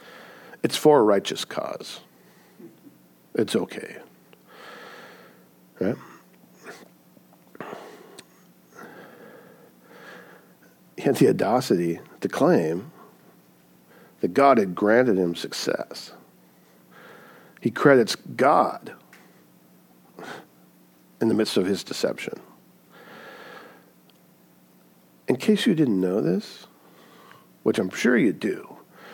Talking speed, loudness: 80 wpm, -23 LUFS